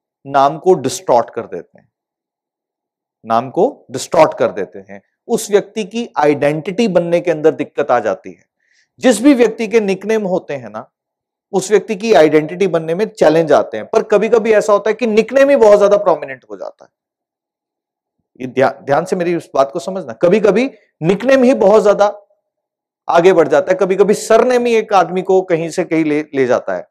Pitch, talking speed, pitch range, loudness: 200 Hz, 195 wpm, 165-220 Hz, -13 LUFS